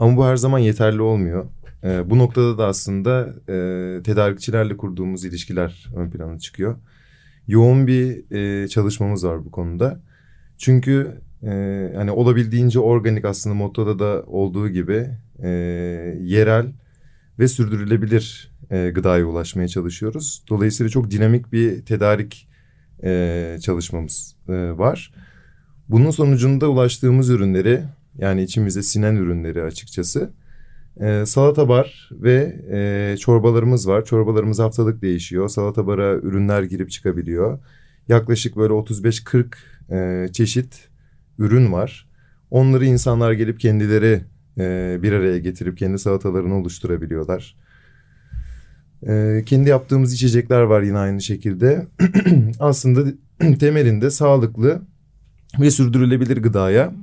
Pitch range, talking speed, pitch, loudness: 95-130 Hz, 110 wpm, 110 Hz, -18 LUFS